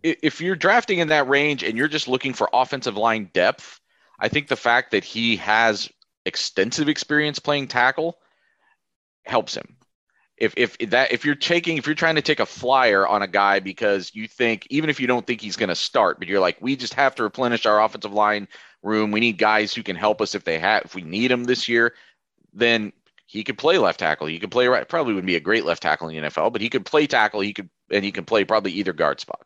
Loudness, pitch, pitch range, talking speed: -21 LUFS, 120 Hz, 105-145 Hz, 240 wpm